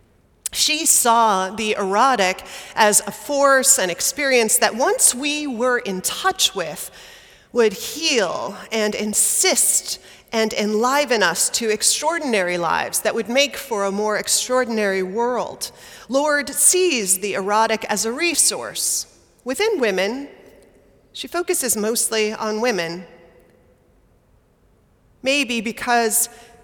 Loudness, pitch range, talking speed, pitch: -18 LUFS, 210-270 Hz, 115 wpm, 230 Hz